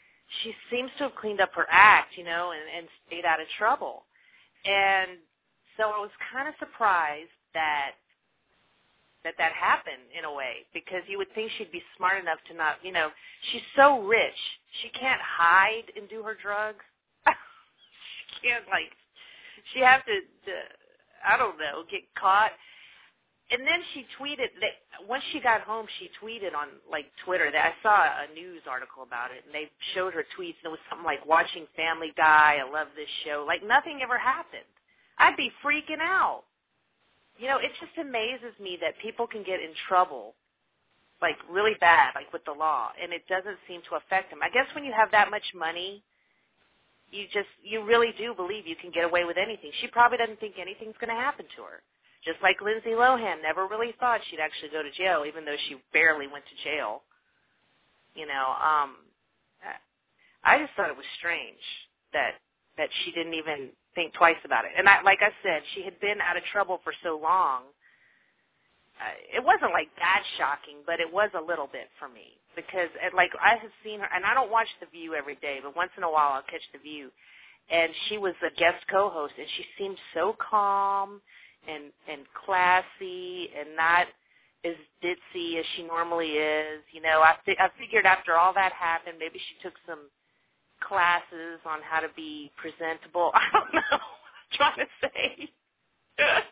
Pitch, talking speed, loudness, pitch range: 185 Hz, 190 wpm, -26 LUFS, 165-230 Hz